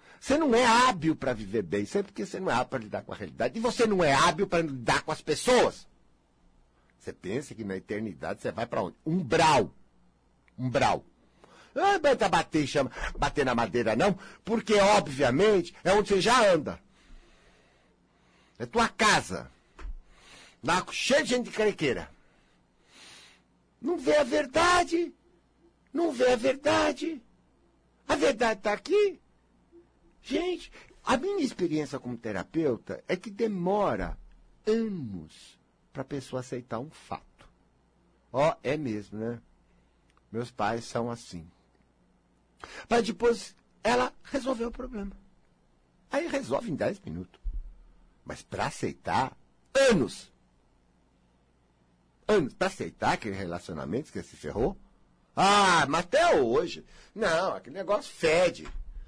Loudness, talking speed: -28 LUFS, 140 wpm